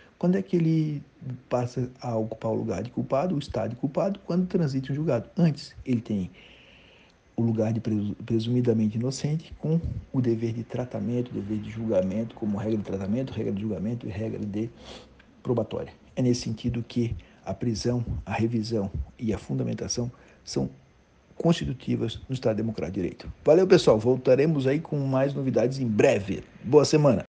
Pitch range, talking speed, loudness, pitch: 110-135 Hz, 165 wpm, -27 LUFS, 120 Hz